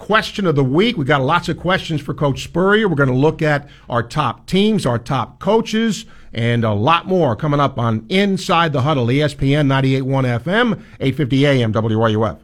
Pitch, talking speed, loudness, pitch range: 145 Hz, 190 wpm, -17 LUFS, 130-180 Hz